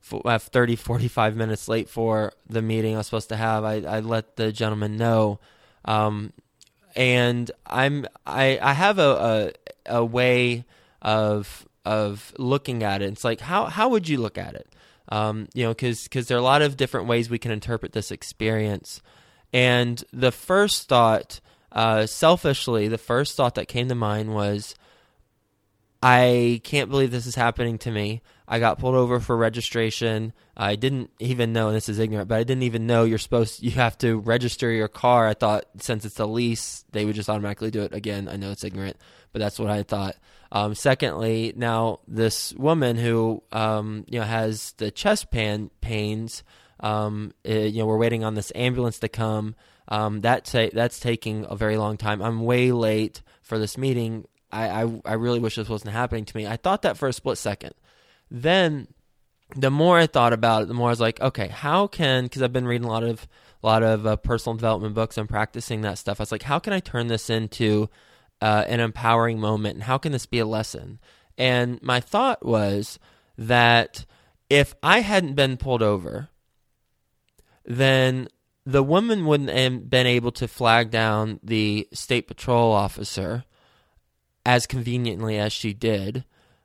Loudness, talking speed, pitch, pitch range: -23 LUFS, 190 wpm, 115 Hz, 110-125 Hz